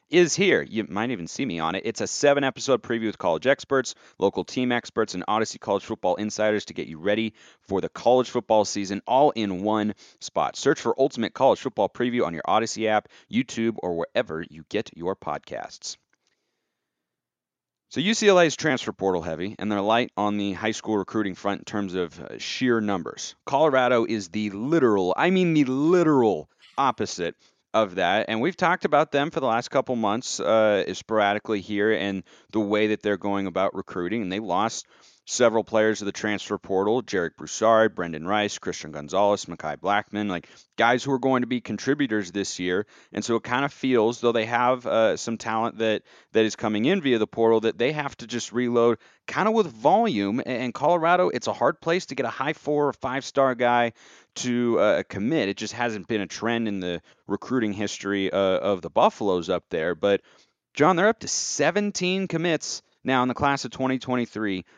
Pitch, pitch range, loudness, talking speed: 115 Hz, 105-130 Hz, -24 LUFS, 200 wpm